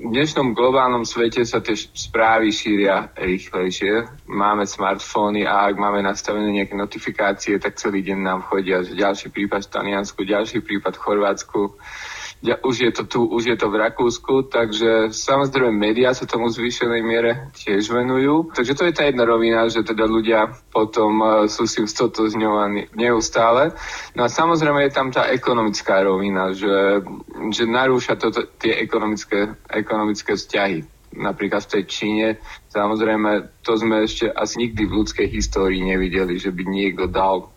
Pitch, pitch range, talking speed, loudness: 110 Hz, 100-115 Hz, 160 wpm, -20 LUFS